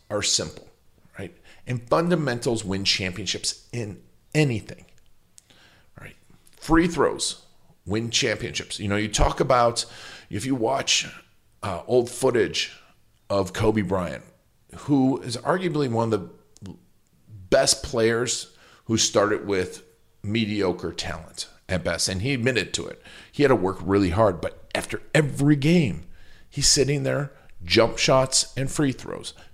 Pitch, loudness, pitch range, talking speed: 115 Hz, -23 LUFS, 100-135 Hz, 135 wpm